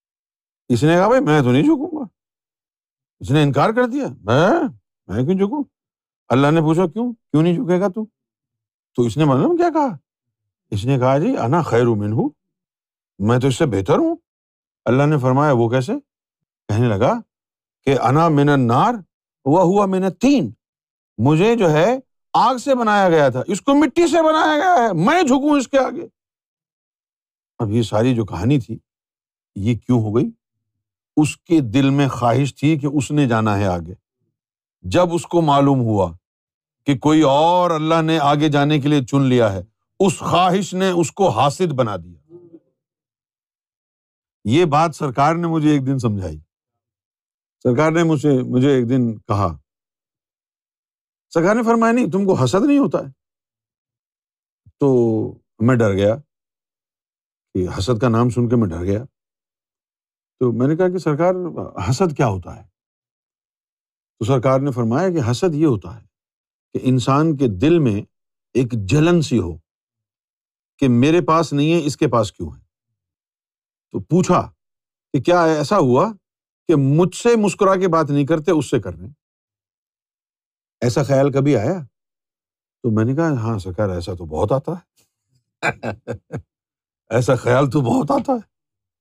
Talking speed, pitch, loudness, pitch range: 160 wpm, 135 Hz, -17 LUFS, 115-170 Hz